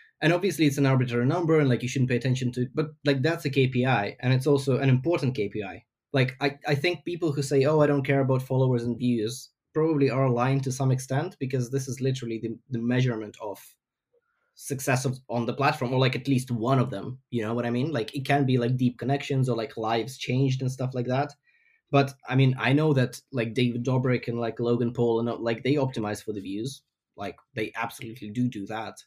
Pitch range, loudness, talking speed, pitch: 120-140 Hz, -26 LUFS, 230 wpm, 130 Hz